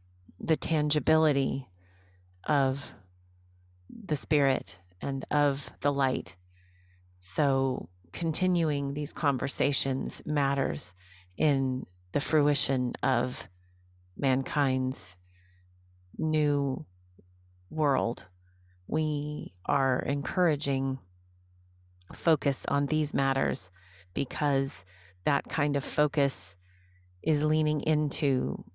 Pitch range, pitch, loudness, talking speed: 90-145 Hz, 130 Hz, -28 LUFS, 75 wpm